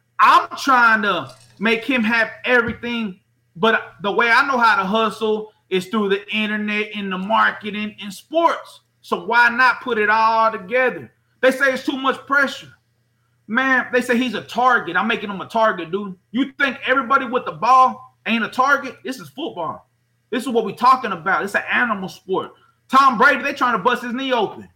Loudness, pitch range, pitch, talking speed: -18 LUFS, 205-255 Hz, 225 Hz, 195 wpm